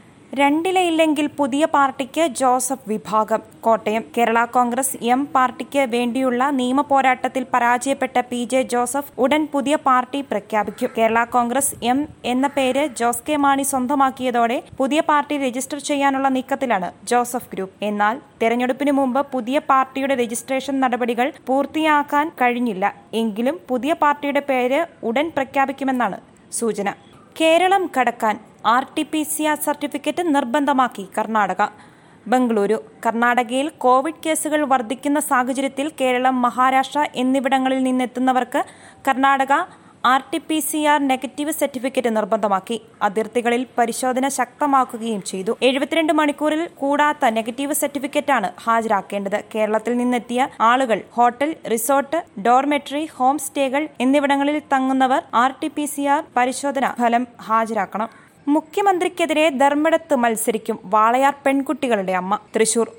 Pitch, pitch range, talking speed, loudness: 265 Hz, 240-285 Hz, 110 wpm, -20 LUFS